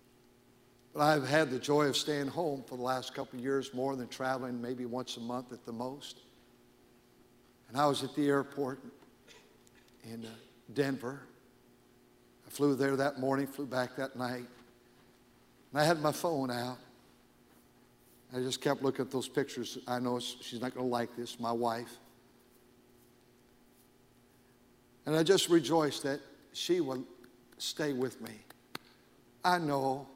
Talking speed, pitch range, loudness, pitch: 150 wpm, 120-140 Hz, -34 LUFS, 130 Hz